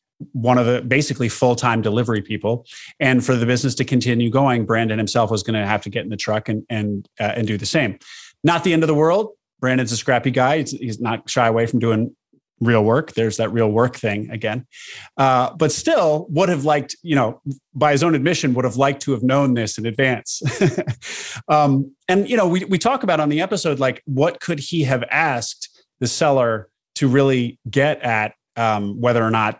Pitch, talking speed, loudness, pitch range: 125 Hz, 210 wpm, -19 LUFS, 115-145 Hz